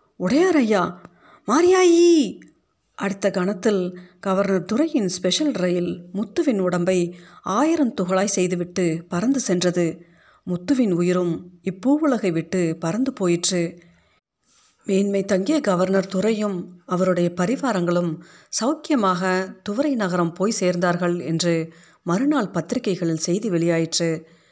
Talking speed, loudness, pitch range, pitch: 95 wpm, -21 LUFS, 175-220 Hz, 185 Hz